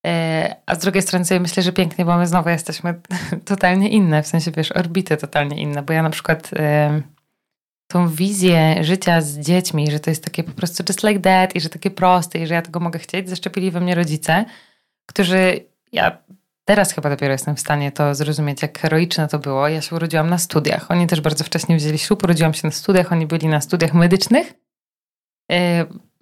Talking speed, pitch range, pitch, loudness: 200 wpm, 155-185 Hz, 170 Hz, -18 LUFS